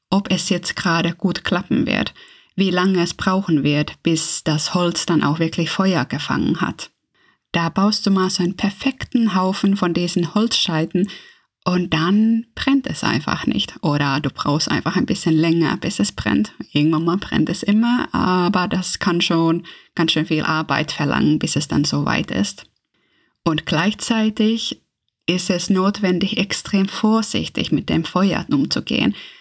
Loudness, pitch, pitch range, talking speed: -19 LUFS, 180 Hz, 160-200 Hz, 160 wpm